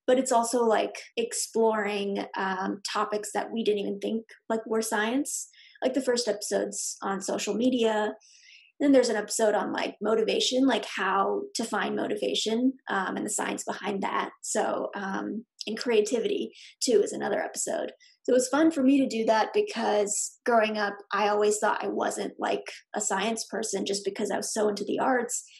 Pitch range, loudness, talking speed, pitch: 210-255 Hz, -27 LUFS, 185 wpm, 225 Hz